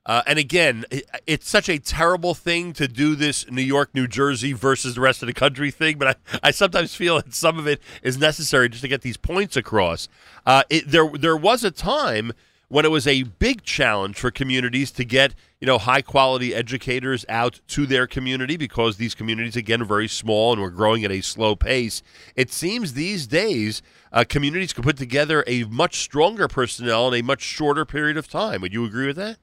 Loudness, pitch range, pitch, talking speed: -21 LUFS, 120-155 Hz, 135 Hz, 210 wpm